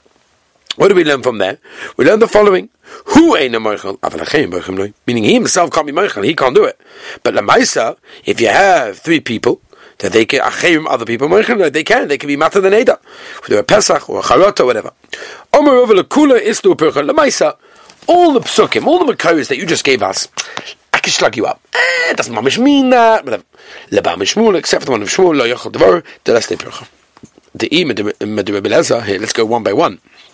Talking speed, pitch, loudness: 200 wpm, 335 Hz, -12 LUFS